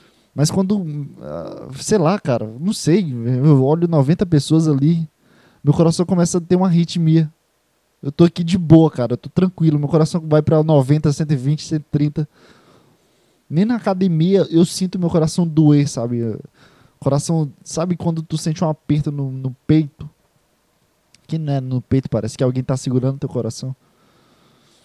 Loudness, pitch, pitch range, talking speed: -17 LUFS, 155 Hz, 140-170 Hz, 160 wpm